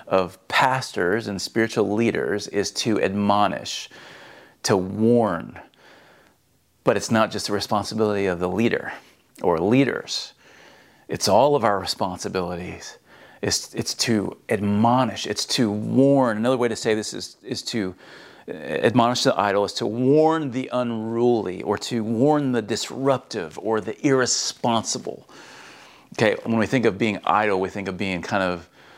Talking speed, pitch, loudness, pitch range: 145 wpm, 110 Hz, -22 LUFS, 100-120 Hz